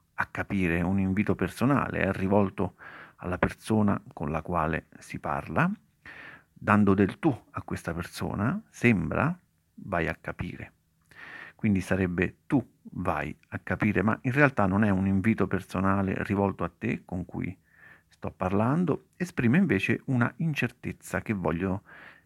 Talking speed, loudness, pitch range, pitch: 140 wpm, -28 LUFS, 95-110 Hz, 100 Hz